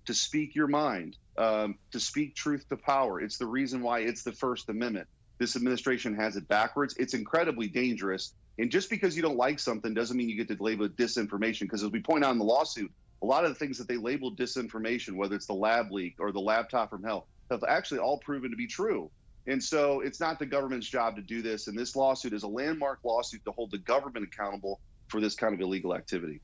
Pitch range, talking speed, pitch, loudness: 105-135 Hz, 235 wpm, 120 Hz, -31 LUFS